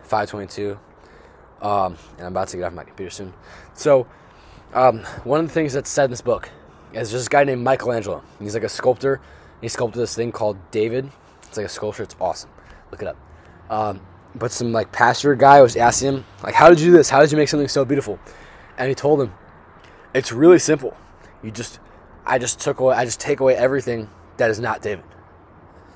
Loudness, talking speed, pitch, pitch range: -18 LUFS, 210 wpm, 120 Hz, 105-135 Hz